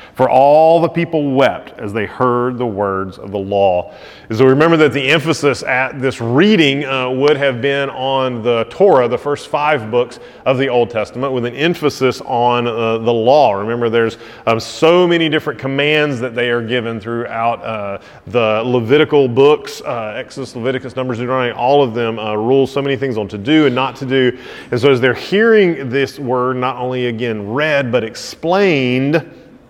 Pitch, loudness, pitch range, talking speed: 130 Hz, -15 LUFS, 120-145 Hz, 190 wpm